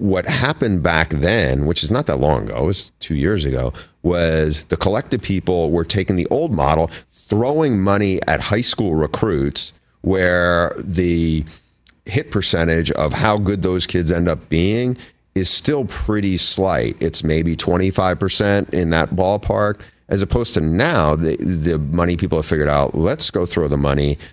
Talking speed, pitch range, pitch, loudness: 170 wpm, 80-100 Hz, 90 Hz, -18 LUFS